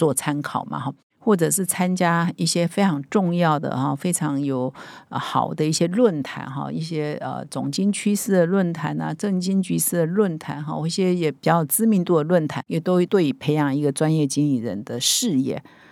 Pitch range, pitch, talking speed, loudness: 145-185 Hz, 170 Hz, 275 characters per minute, -22 LUFS